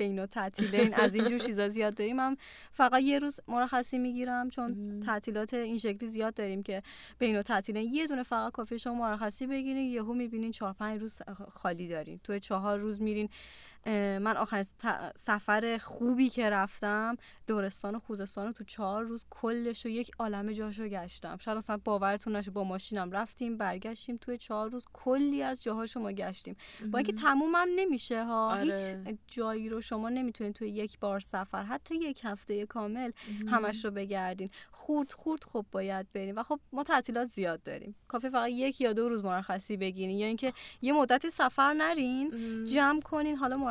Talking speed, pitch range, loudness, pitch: 180 wpm, 205-245 Hz, -33 LUFS, 225 Hz